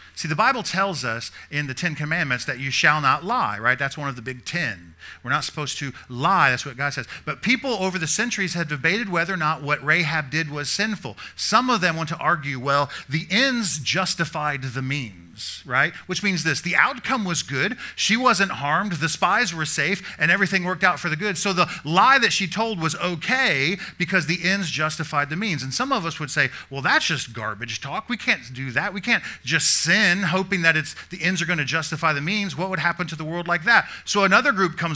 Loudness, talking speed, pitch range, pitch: -21 LUFS, 230 wpm, 145-195 Hz, 165 Hz